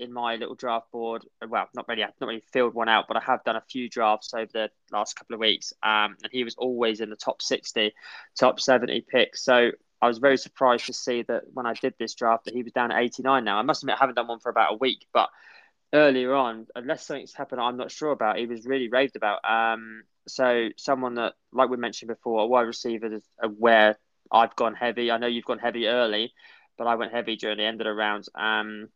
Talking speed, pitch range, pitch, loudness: 245 wpm, 110-125 Hz, 115 Hz, -25 LUFS